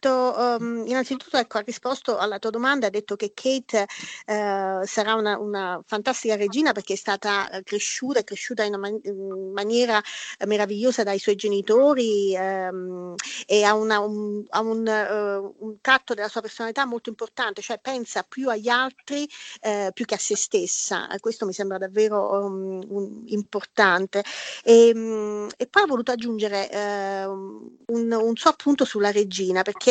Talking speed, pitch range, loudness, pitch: 165 wpm, 200-240 Hz, -24 LUFS, 215 Hz